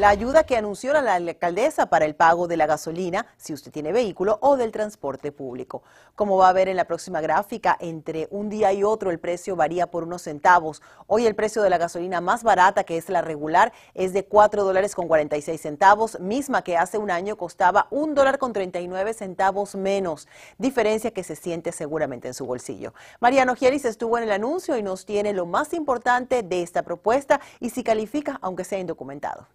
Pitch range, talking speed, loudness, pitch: 170-220 Hz, 205 wpm, -22 LUFS, 190 Hz